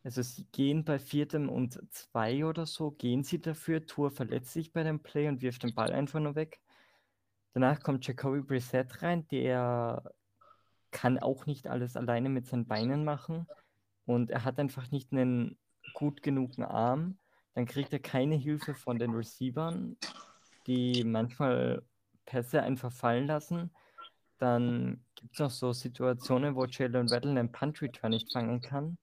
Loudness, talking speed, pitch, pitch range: -33 LUFS, 160 wpm, 130 Hz, 120-150 Hz